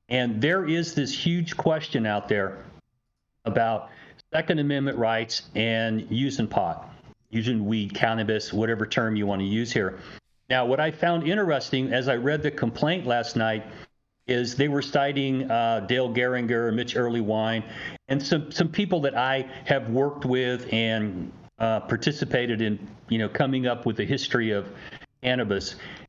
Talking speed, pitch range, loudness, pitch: 155 wpm, 110-140 Hz, -26 LUFS, 120 Hz